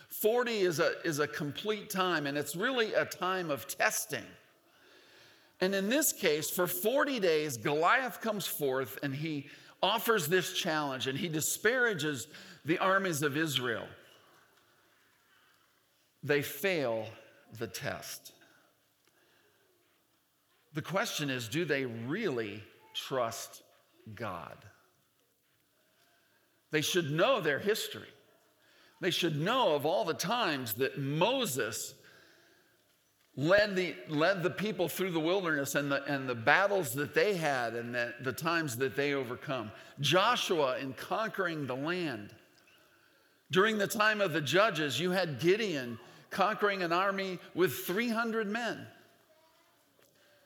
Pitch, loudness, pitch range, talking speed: 170 Hz, -32 LUFS, 145-195 Hz, 125 wpm